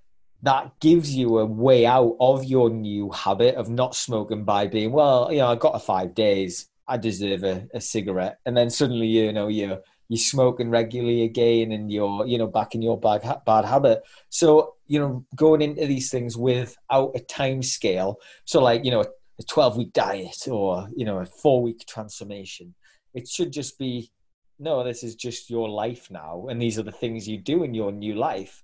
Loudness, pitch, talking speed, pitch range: -23 LUFS, 115 Hz, 200 wpm, 110-130 Hz